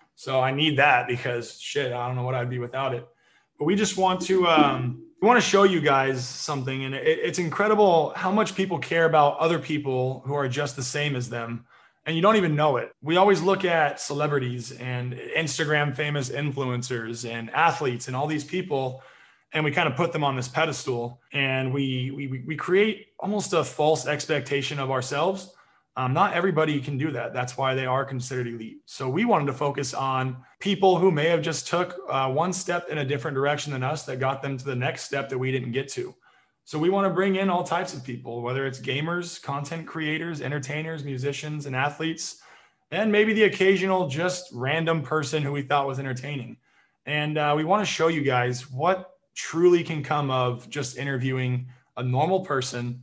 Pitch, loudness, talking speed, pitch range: 145 Hz, -25 LUFS, 205 wpm, 130-170 Hz